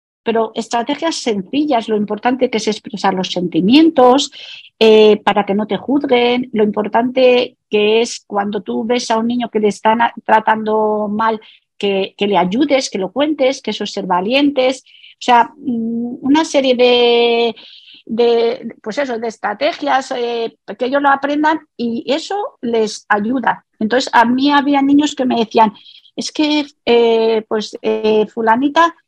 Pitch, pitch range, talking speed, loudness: 235 Hz, 215-265 Hz, 160 wpm, -15 LUFS